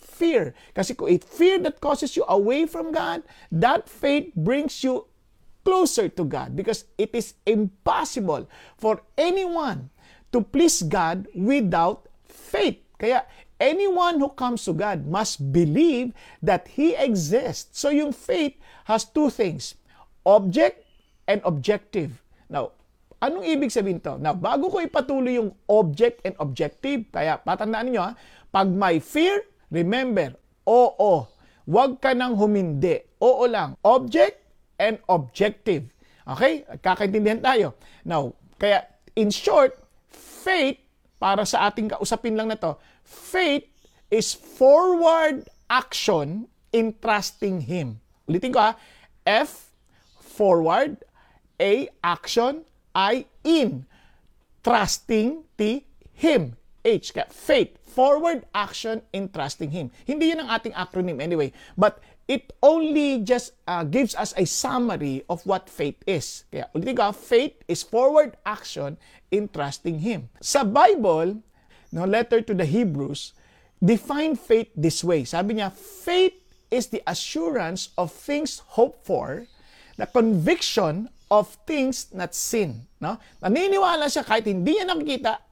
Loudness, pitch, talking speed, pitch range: -23 LUFS, 225 Hz, 130 wpm, 190-285 Hz